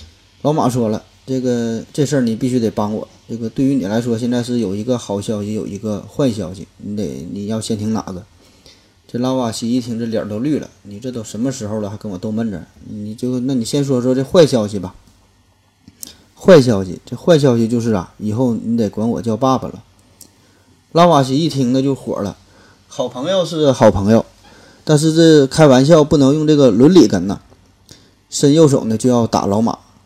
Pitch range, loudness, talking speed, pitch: 100-130 Hz, -15 LUFS, 285 characters per minute, 115 Hz